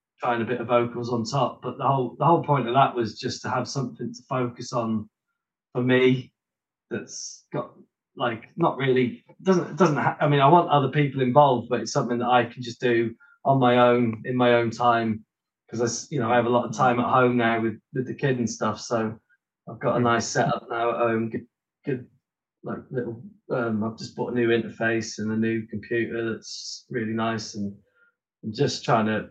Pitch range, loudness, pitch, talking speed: 115-135 Hz, -24 LUFS, 120 Hz, 215 wpm